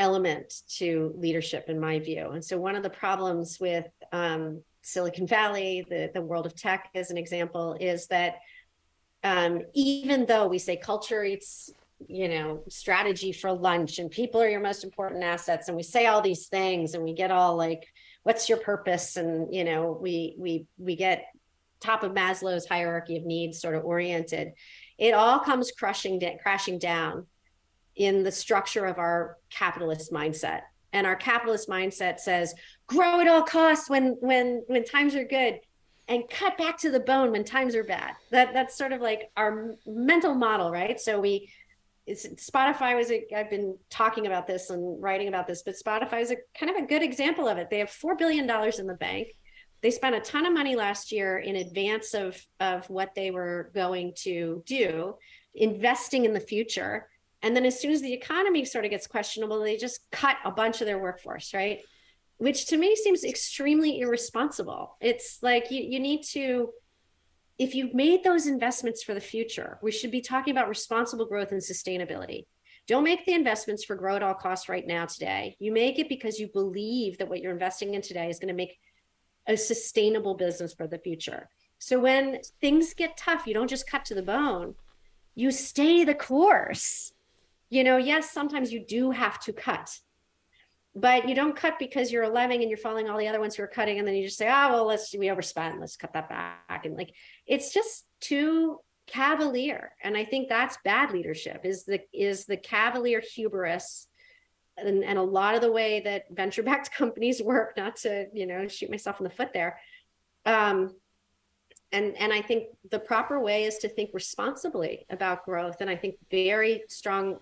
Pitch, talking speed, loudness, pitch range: 210 Hz, 190 wpm, -27 LUFS, 185-250 Hz